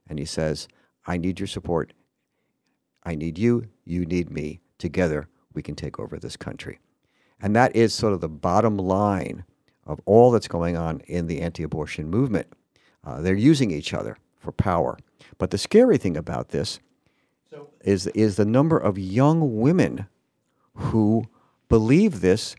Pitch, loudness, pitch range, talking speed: 95 Hz, -23 LUFS, 85-115 Hz, 160 wpm